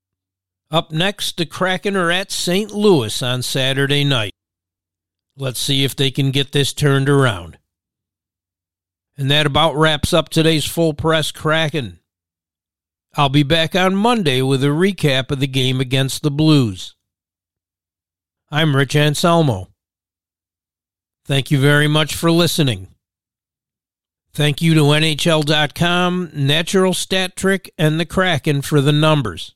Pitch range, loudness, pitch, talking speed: 95-160 Hz, -16 LUFS, 140 Hz, 130 wpm